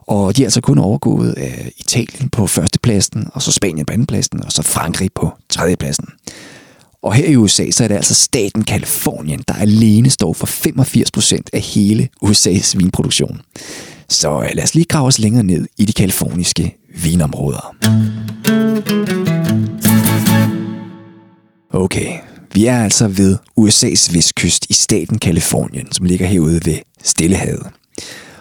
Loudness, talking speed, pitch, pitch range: -13 LUFS, 140 wpm, 110 Hz, 95-125 Hz